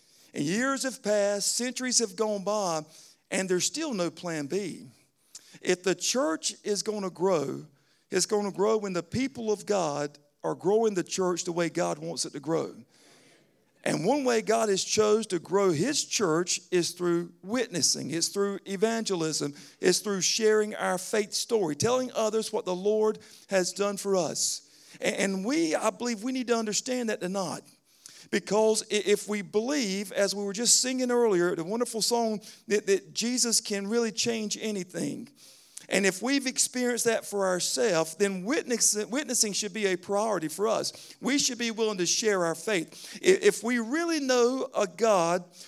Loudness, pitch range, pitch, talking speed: -27 LUFS, 185-235 Hz, 210 Hz, 175 wpm